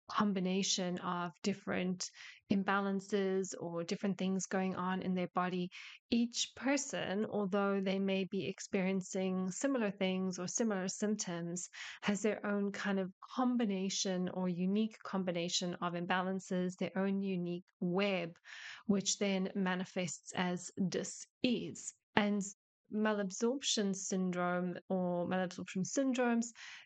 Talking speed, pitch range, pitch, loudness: 115 wpm, 180-205 Hz, 190 Hz, -37 LUFS